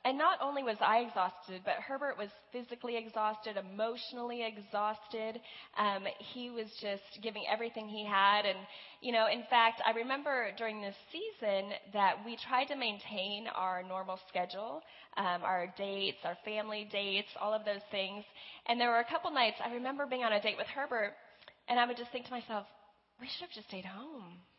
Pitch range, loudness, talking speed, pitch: 200-240 Hz, -36 LUFS, 185 wpm, 215 Hz